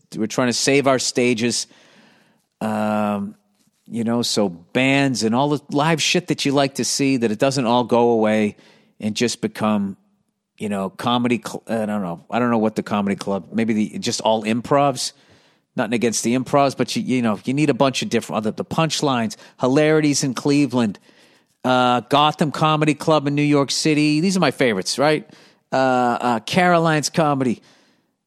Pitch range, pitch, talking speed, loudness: 110-145 Hz, 125 Hz, 185 wpm, -19 LUFS